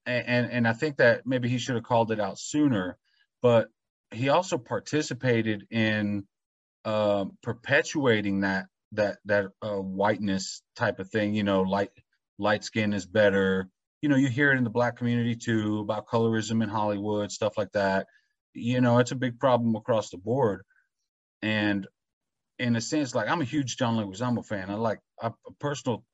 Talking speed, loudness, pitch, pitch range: 185 wpm, -27 LUFS, 115 Hz, 105-125 Hz